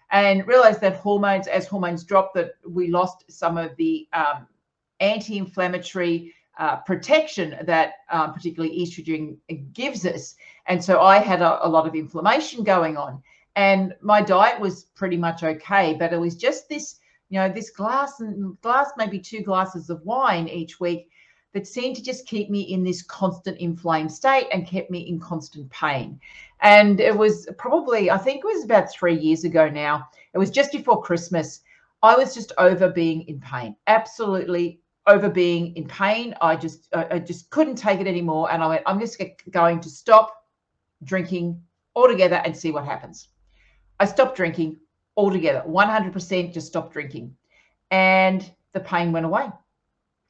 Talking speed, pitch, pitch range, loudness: 170 wpm, 185 Hz, 165-210 Hz, -21 LUFS